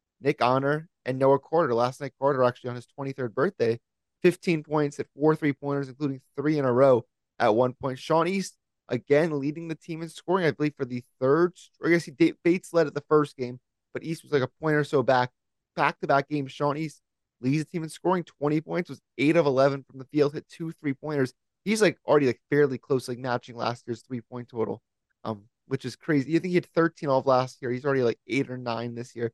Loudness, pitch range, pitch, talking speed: -26 LUFS, 125-155 Hz, 140 Hz, 235 wpm